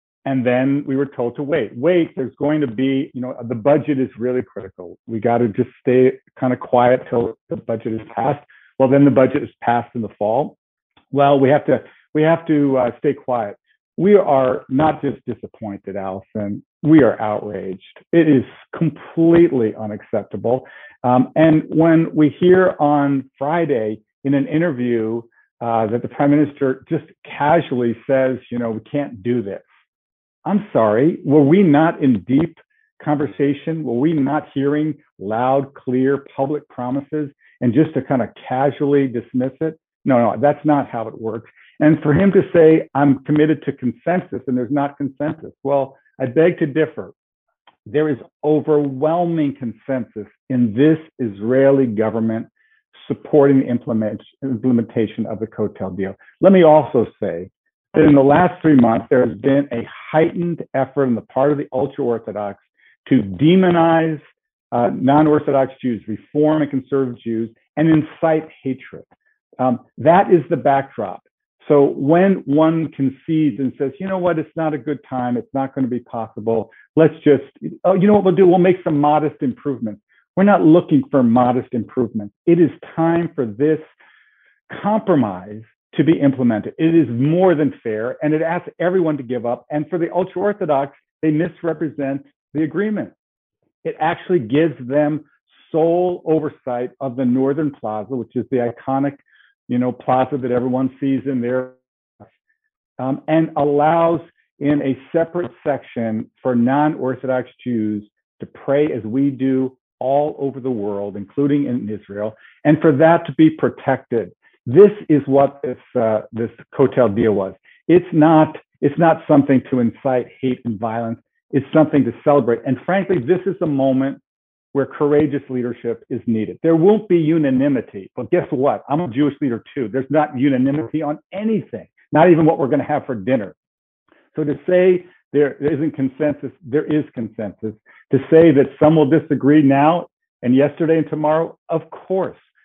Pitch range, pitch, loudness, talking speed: 125-155 Hz, 140 Hz, -18 LUFS, 165 wpm